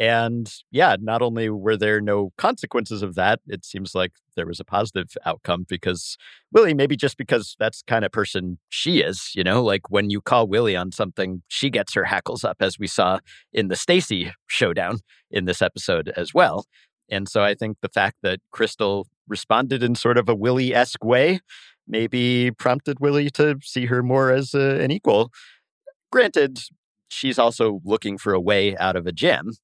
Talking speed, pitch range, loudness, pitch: 190 wpm, 100-135 Hz, -21 LUFS, 115 Hz